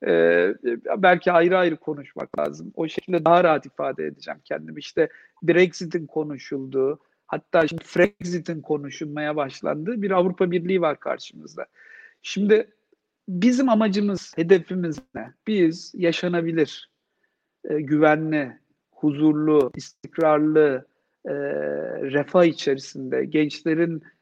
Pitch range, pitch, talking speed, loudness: 150-180 Hz, 160 Hz, 100 wpm, -22 LUFS